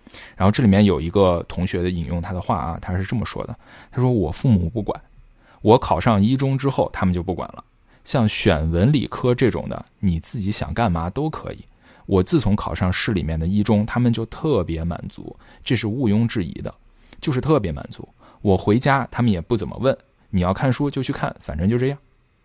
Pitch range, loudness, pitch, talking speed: 90-125 Hz, -21 LUFS, 105 Hz, 300 characters per minute